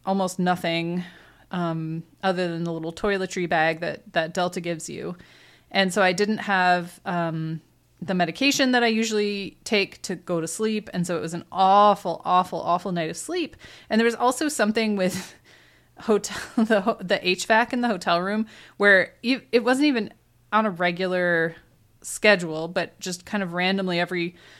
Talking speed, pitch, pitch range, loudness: 170 wpm, 185 Hz, 170-210 Hz, -23 LUFS